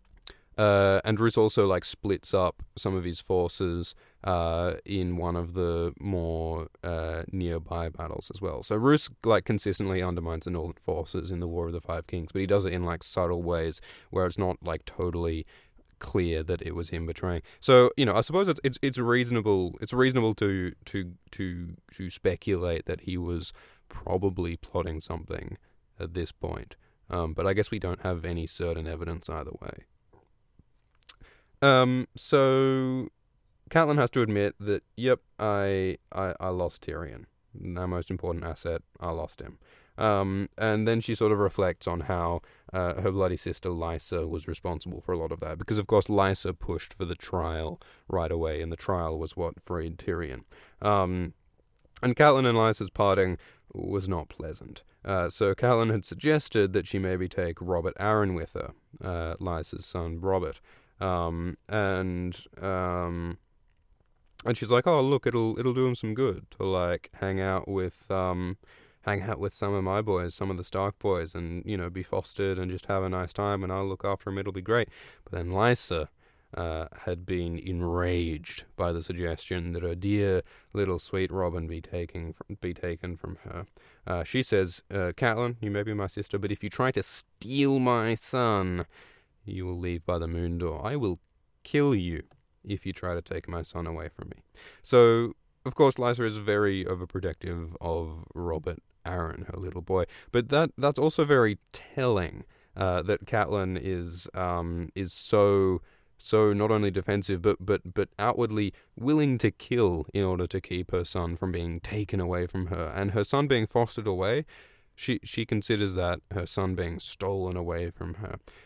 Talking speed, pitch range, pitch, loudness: 180 wpm, 85-105 Hz, 95 Hz, -29 LUFS